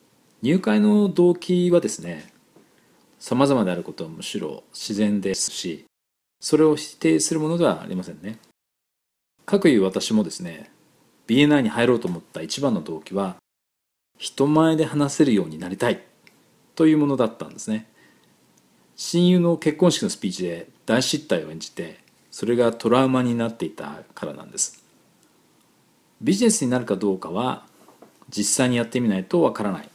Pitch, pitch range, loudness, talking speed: 130 Hz, 100-165 Hz, -22 LUFS, 320 characters per minute